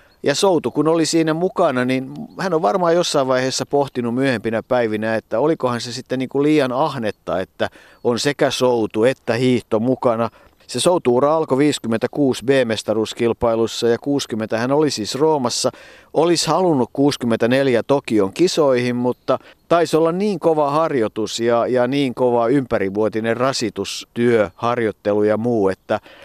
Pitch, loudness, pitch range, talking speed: 125 Hz, -18 LUFS, 115-145 Hz, 140 wpm